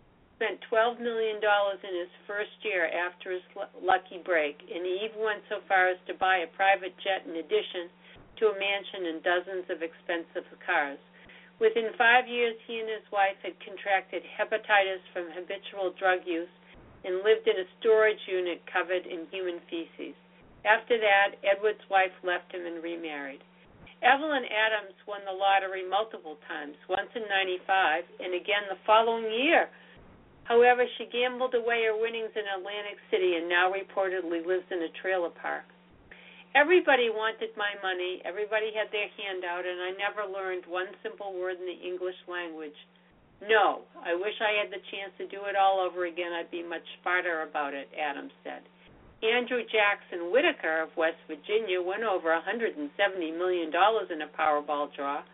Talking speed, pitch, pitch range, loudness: 165 wpm, 190 Hz, 175-215 Hz, -29 LUFS